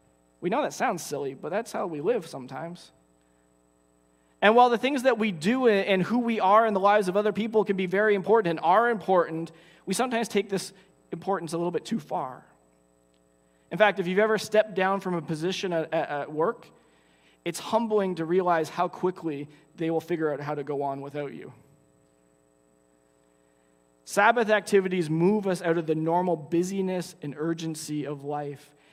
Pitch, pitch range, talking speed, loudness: 165 Hz, 130-195 Hz, 180 wpm, -26 LUFS